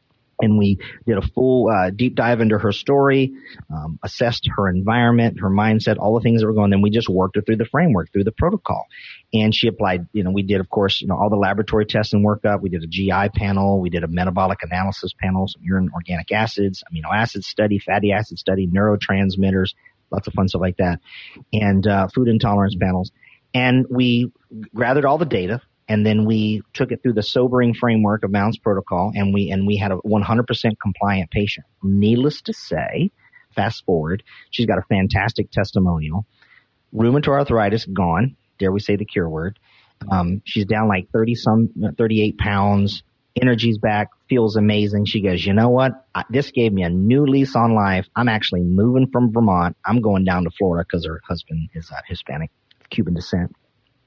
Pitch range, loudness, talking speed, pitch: 95-115 Hz, -19 LUFS, 195 wpm, 105 Hz